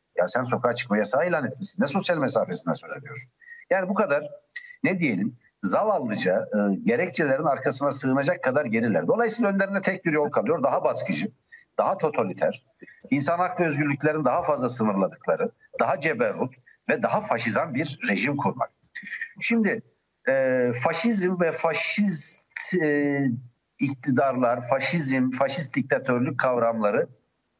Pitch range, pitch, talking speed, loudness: 130-205 Hz, 160 Hz, 130 wpm, -24 LUFS